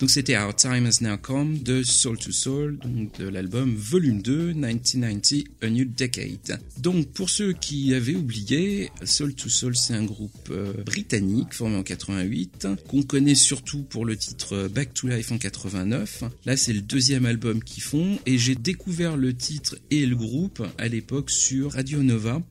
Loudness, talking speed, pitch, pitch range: -24 LUFS, 180 wpm, 130 Hz, 110-140 Hz